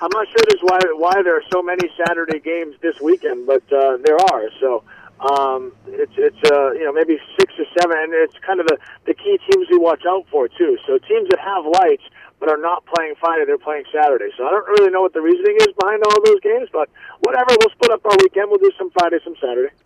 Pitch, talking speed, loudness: 200 Hz, 250 wpm, -16 LUFS